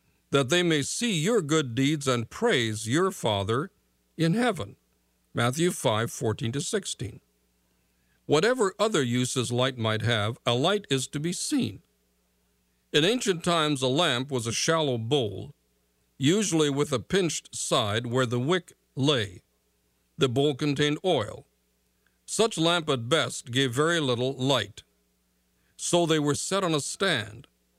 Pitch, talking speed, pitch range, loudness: 130 Hz, 145 wpm, 95-160 Hz, -26 LUFS